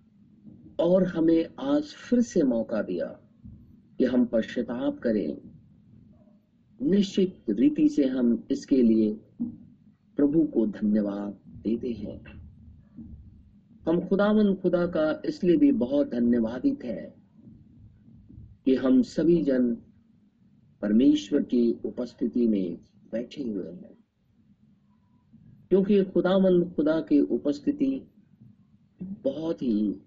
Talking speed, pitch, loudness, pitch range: 100 wpm, 145 Hz, -26 LUFS, 115-195 Hz